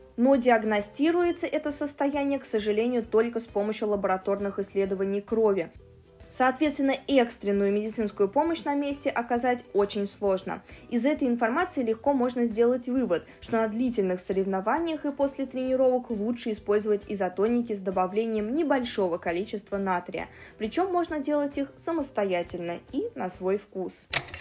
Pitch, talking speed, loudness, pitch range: 225 Hz, 130 wpm, -27 LUFS, 200-275 Hz